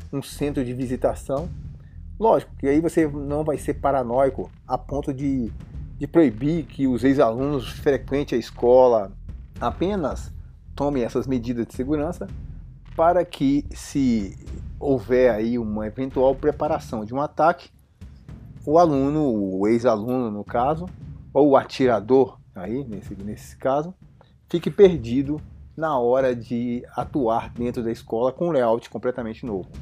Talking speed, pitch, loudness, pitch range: 135 wpm, 130 Hz, -22 LUFS, 115-145 Hz